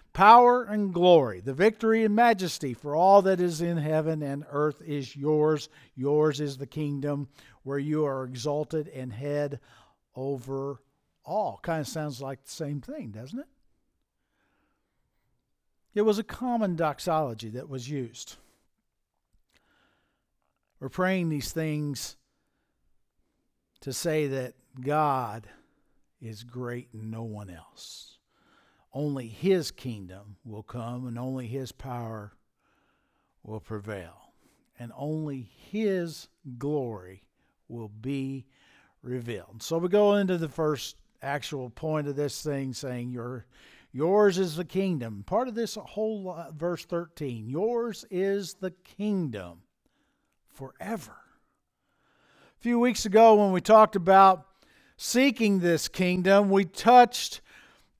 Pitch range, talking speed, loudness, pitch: 130-185 Hz, 125 wpm, -26 LUFS, 150 Hz